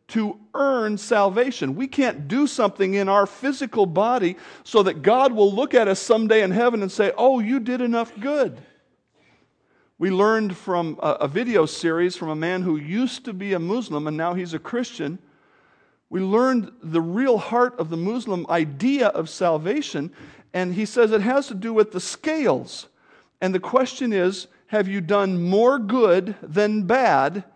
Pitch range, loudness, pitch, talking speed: 180-240 Hz, -22 LUFS, 205 Hz, 175 wpm